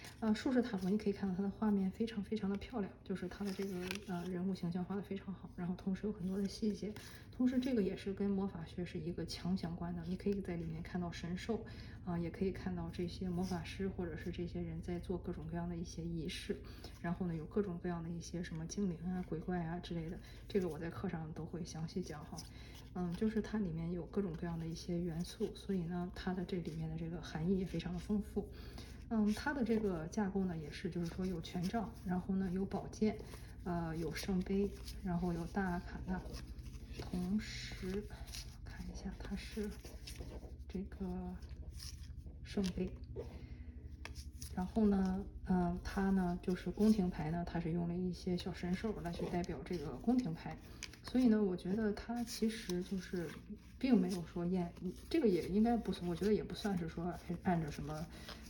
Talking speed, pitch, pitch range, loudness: 290 characters per minute, 180 Hz, 170-195 Hz, -40 LUFS